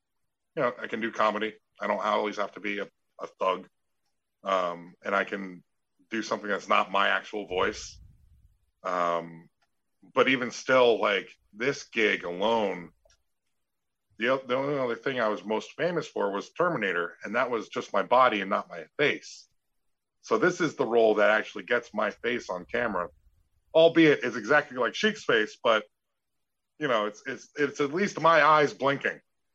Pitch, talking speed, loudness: 110 Hz, 175 wpm, -27 LUFS